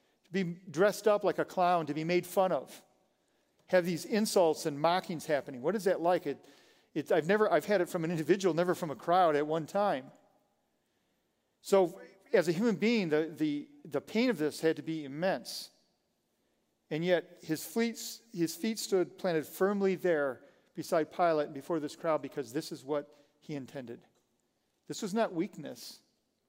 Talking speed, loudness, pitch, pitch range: 180 wpm, -32 LUFS, 175 Hz, 155-195 Hz